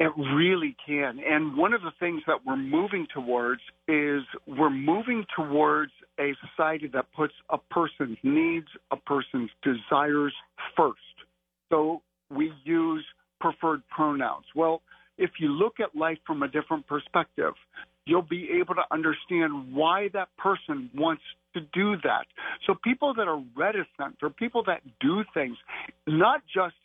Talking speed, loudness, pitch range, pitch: 150 wpm, -28 LUFS, 150-195 Hz, 160 Hz